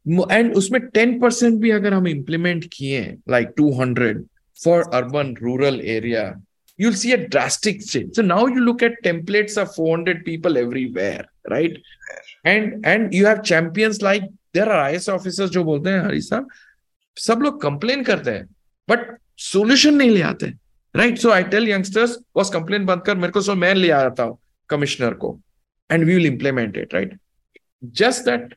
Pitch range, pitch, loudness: 150-220 Hz, 185 Hz, -19 LUFS